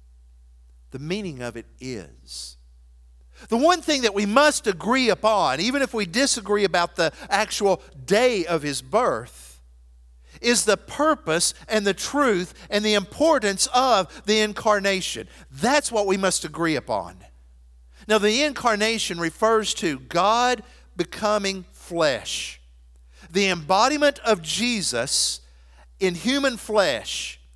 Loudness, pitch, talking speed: -22 LUFS, 190 Hz, 125 wpm